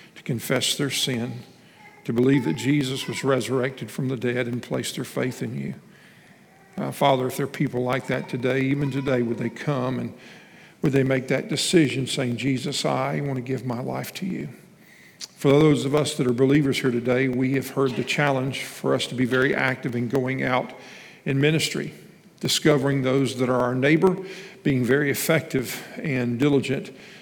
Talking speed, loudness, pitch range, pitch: 185 wpm, -24 LUFS, 130-145 Hz, 135 Hz